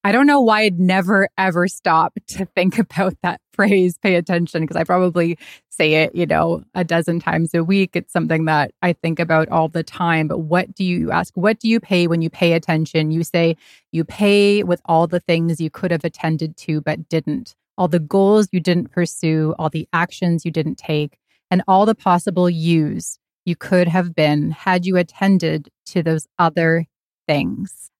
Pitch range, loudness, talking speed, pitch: 160-185 Hz, -18 LUFS, 195 wpm, 175 Hz